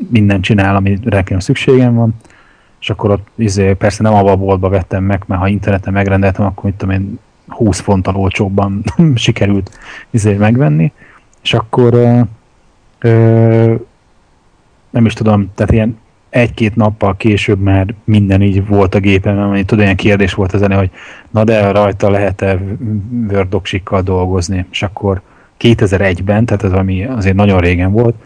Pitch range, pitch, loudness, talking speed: 95-115 Hz, 100 Hz, -12 LUFS, 150 wpm